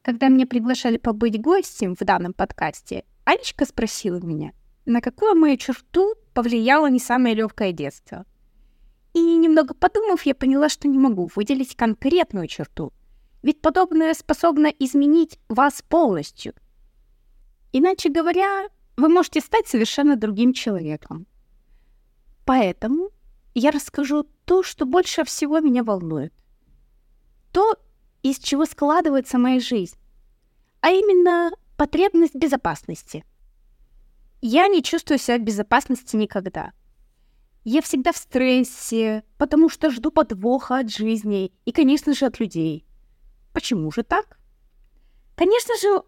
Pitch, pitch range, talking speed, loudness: 275 Hz, 230-325 Hz, 120 wpm, -20 LUFS